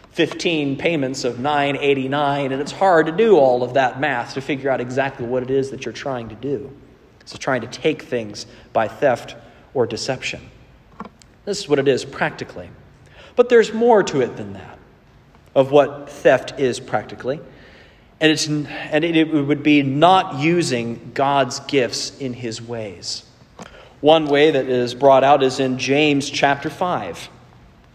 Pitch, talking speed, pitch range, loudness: 140 Hz, 165 wpm, 130-155 Hz, -19 LUFS